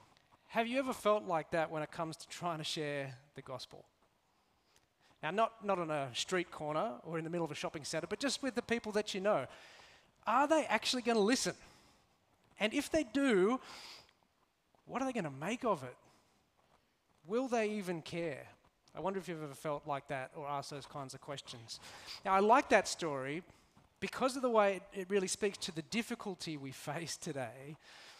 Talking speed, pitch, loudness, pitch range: 195 wpm, 185 Hz, -36 LUFS, 150-220 Hz